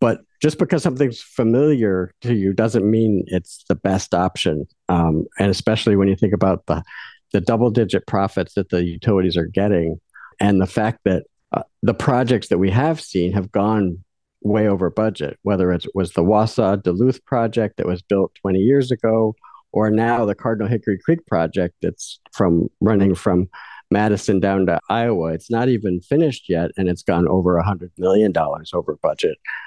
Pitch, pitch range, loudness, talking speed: 100 Hz, 90-115 Hz, -19 LUFS, 175 wpm